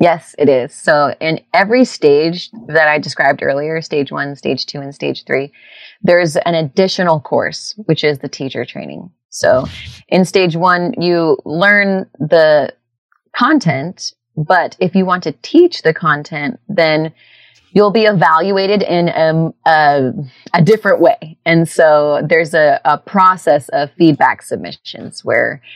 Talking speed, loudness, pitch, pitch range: 145 wpm, -13 LUFS, 165 Hz, 150-185 Hz